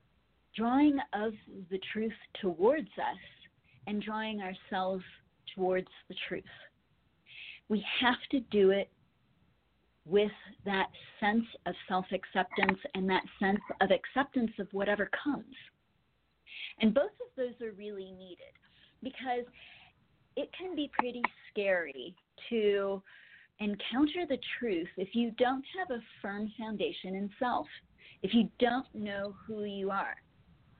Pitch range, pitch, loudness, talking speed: 195-245 Hz, 210 Hz, -33 LUFS, 125 wpm